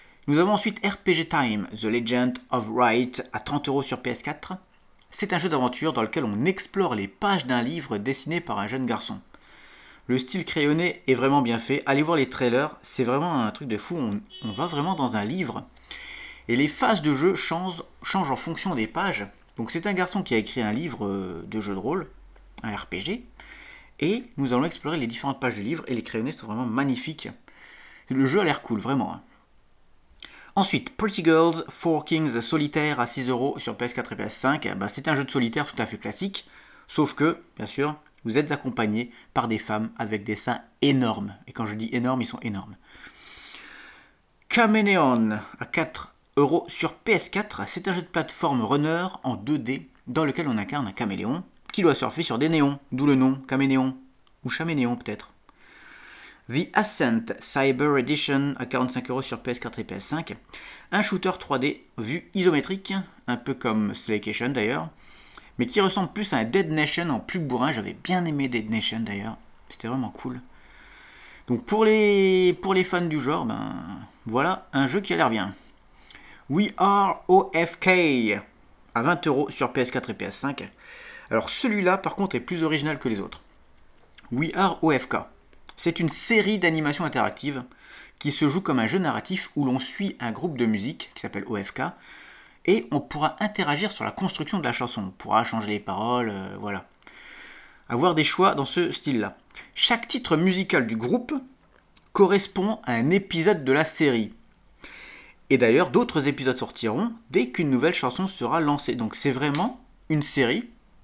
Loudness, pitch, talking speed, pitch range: -25 LUFS, 145 Hz, 175 wpm, 125-180 Hz